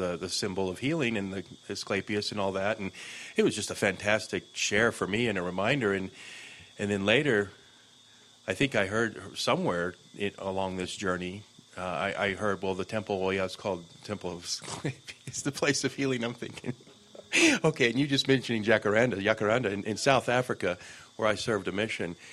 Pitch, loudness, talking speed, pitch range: 105 Hz, -29 LUFS, 200 wpm, 95-125 Hz